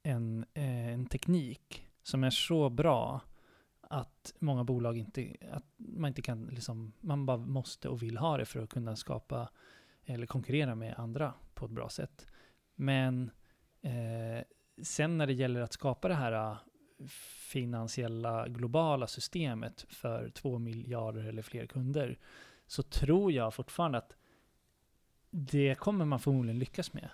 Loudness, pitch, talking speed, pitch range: -36 LUFS, 130 Hz, 145 wpm, 115-145 Hz